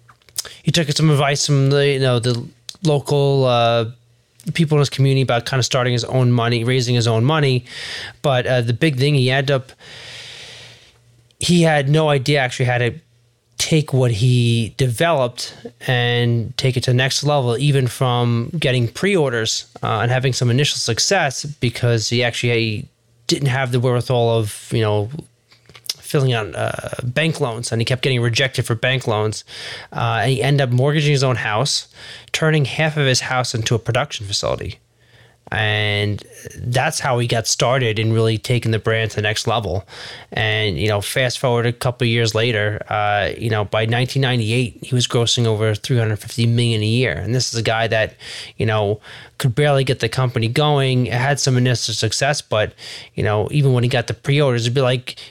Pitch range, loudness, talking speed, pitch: 115-135 Hz, -18 LUFS, 185 wpm, 125 Hz